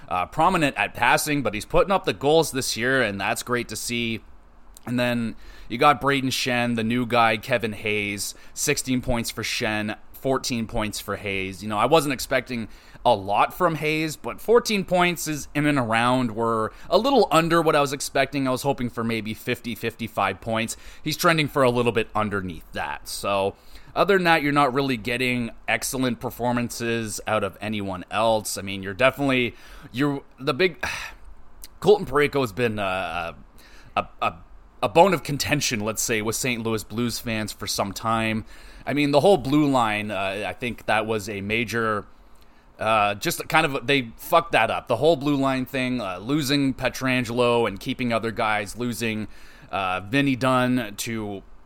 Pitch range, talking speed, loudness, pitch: 110-140 Hz, 180 wpm, -23 LUFS, 120 Hz